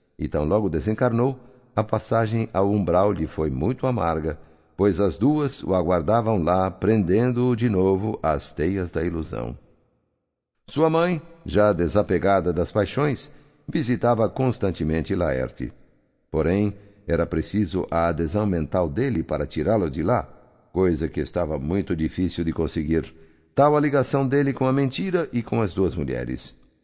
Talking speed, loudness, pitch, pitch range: 145 wpm, -23 LUFS, 95 Hz, 80-115 Hz